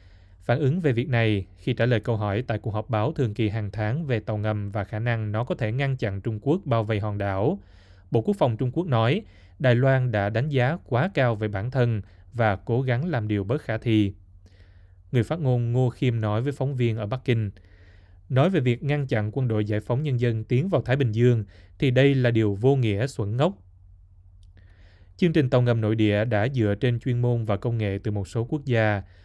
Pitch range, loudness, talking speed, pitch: 100-125 Hz, -25 LUFS, 235 wpm, 115 Hz